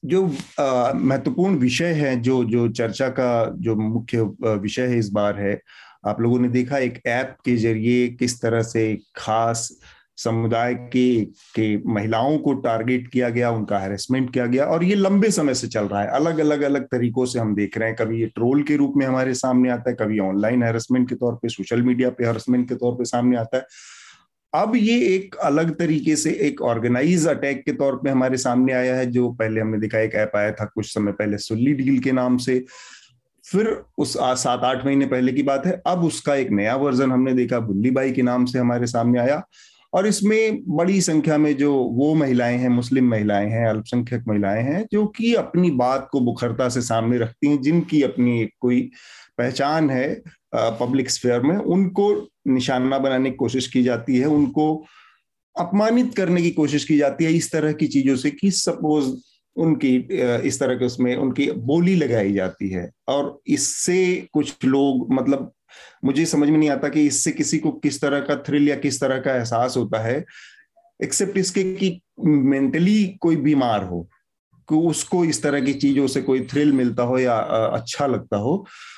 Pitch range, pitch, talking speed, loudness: 120-150 Hz, 130 Hz, 190 wpm, -21 LUFS